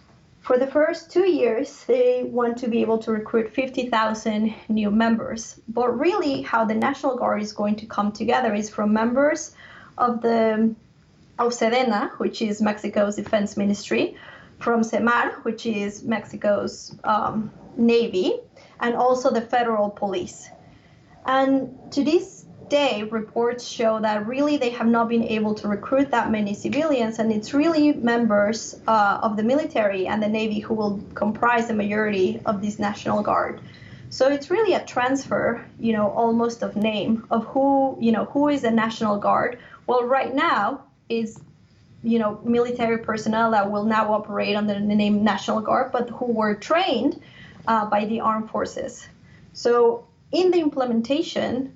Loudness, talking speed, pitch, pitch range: -22 LUFS, 160 wpm, 230 Hz, 215-255 Hz